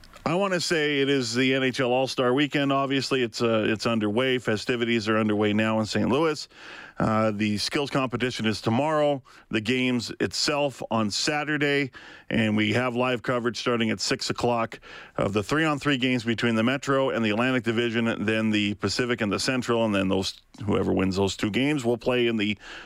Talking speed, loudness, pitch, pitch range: 195 wpm, -25 LUFS, 120 Hz, 110-135 Hz